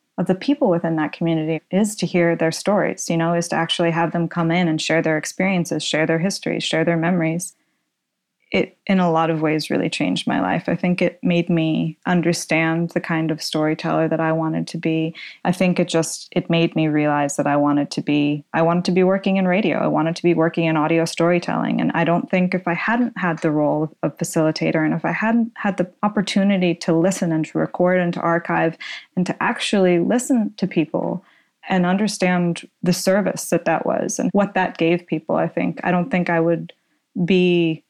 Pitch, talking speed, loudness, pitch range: 170 Hz, 215 wpm, -20 LUFS, 160-185 Hz